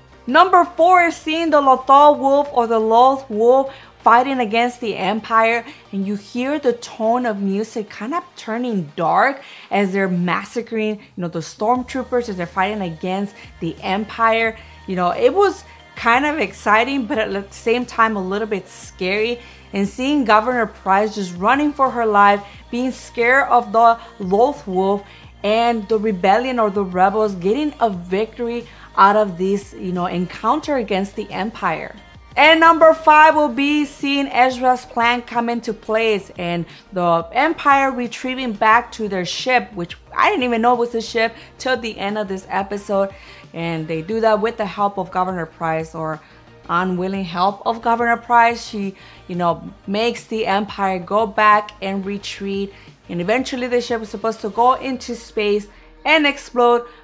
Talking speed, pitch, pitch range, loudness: 165 wpm, 225 Hz, 195-245 Hz, -18 LUFS